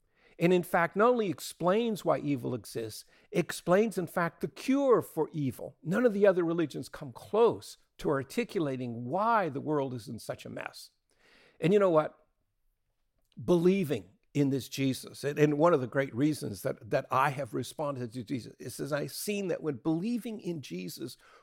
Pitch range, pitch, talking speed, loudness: 135-190 Hz, 155 Hz, 175 wpm, -30 LUFS